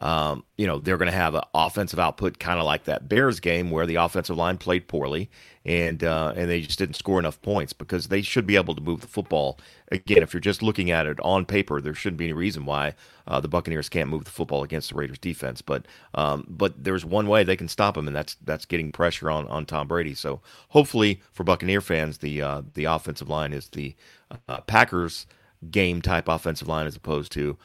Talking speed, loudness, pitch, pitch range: 230 wpm, -25 LUFS, 85 Hz, 75-95 Hz